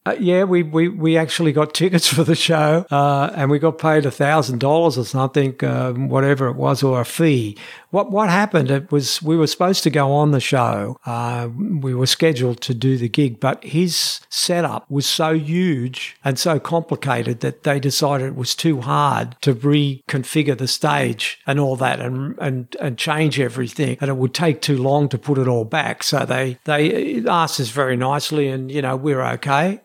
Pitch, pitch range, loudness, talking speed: 145 Hz, 130-160 Hz, -18 LUFS, 200 wpm